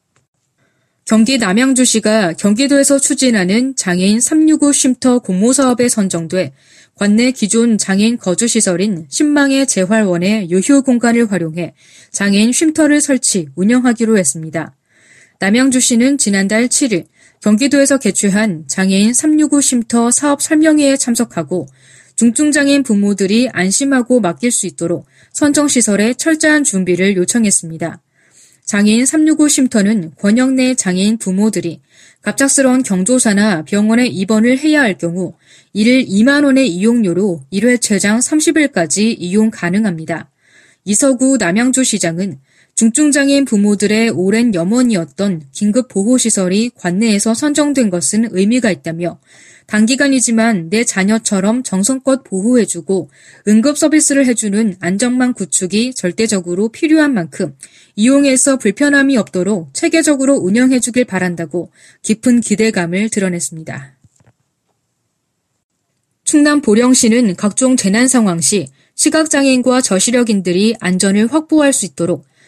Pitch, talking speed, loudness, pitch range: 220 Hz, 300 characters per minute, -12 LUFS, 190-255 Hz